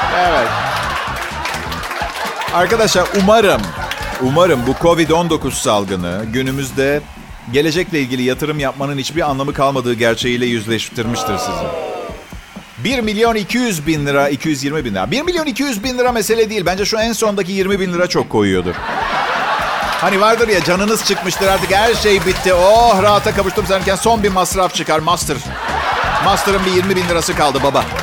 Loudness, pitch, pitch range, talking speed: -15 LUFS, 180 Hz, 140-205 Hz, 145 wpm